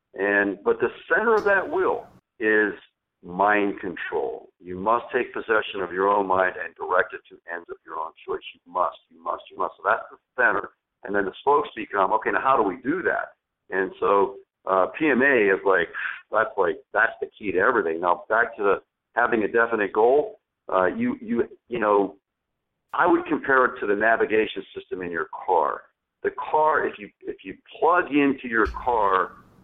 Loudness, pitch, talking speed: -23 LUFS, 395 Hz, 195 wpm